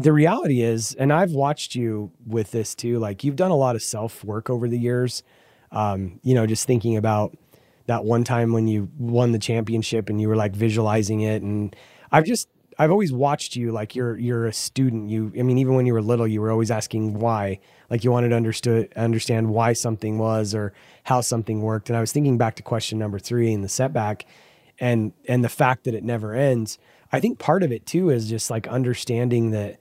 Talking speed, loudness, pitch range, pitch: 220 wpm, -22 LUFS, 110-125 Hz, 115 Hz